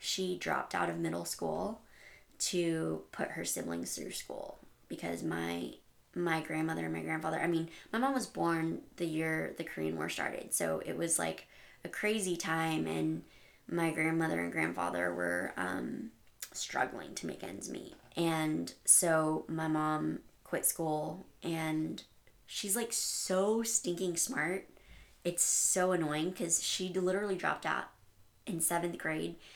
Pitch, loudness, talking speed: 160 Hz, -34 LUFS, 150 wpm